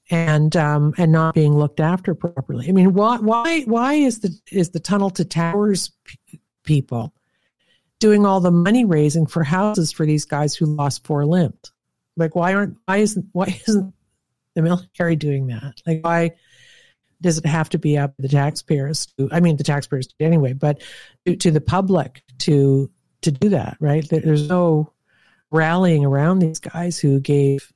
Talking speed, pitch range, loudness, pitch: 180 wpm, 145-185 Hz, -19 LUFS, 165 Hz